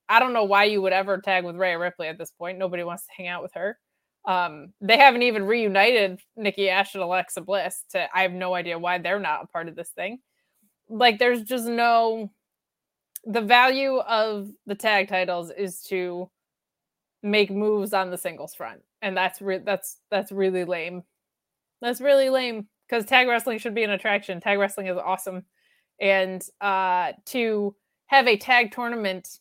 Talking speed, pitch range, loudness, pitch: 185 wpm, 185-225 Hz, -23 LUFS, 200 Hz